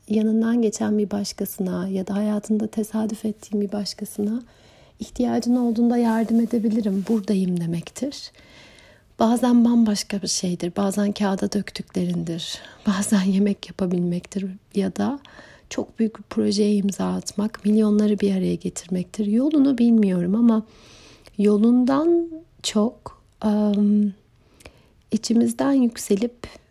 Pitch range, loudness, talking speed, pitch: 200-230 Hz, -22 LUFS, 105 wpm, 210 Hz